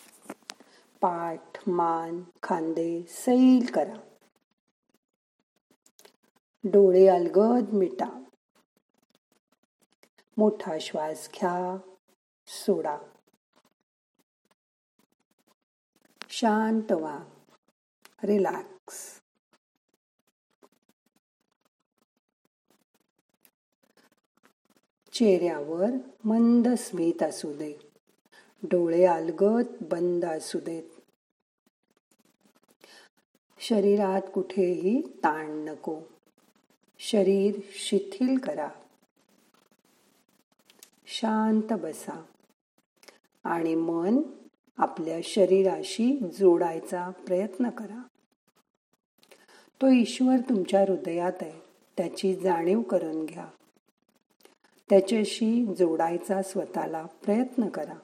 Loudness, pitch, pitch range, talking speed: -26 LUFS, 195 Hz, 175-225 Hz, 55 wpm